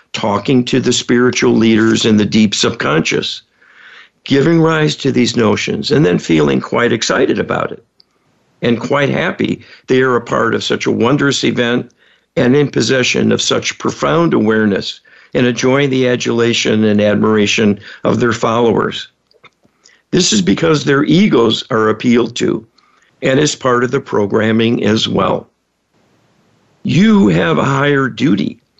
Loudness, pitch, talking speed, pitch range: -13 LUFS, 120 Hz, 145 wpm, 110-140 Hz